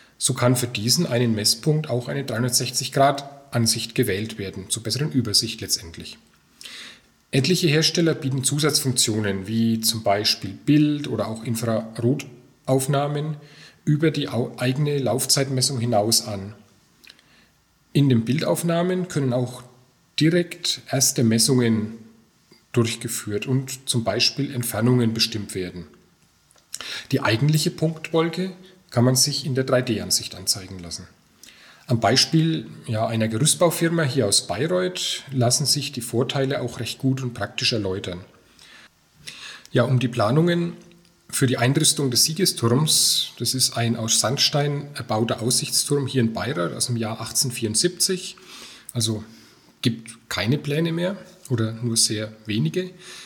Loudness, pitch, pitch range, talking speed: -22 LUFS, 125 Hz, 115-145 Hz, 120 wpm